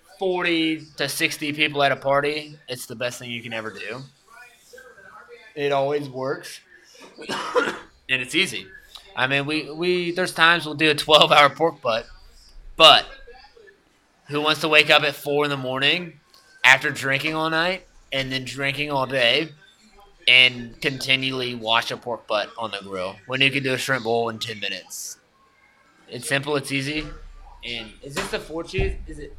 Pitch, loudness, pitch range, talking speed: 145 Hz, -20 LUFS, 130-160 Hz, 175 wpm